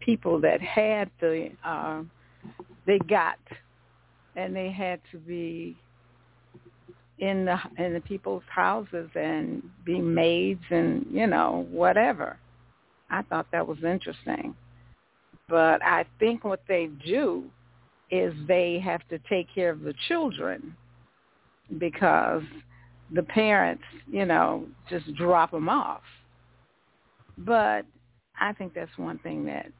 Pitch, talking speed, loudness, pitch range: 170 Hz, 125 wpm, -27 LUFS, 120-185 Hz